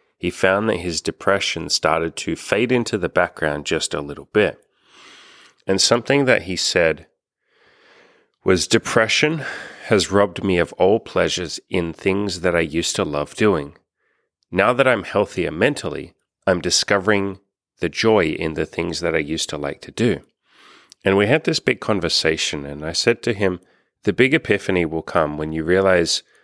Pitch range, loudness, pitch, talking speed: 85-120 Hz, -19 LUFS, 100 Hz, 170 wpm